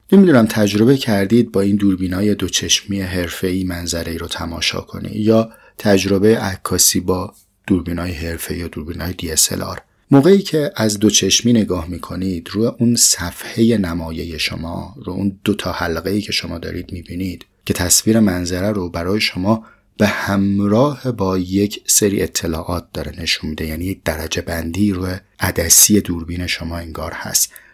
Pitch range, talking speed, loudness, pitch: 85-105 Hz, 150 wpm, -17 LUFS, 95 Hz